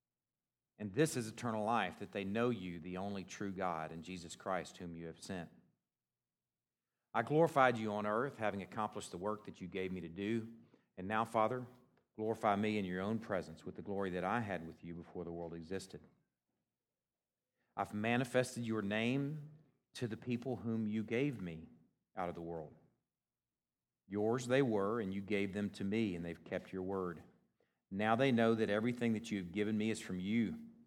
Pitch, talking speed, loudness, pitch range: 105 Hz, 190 wpm, -39 LUFS, 90-115 Hz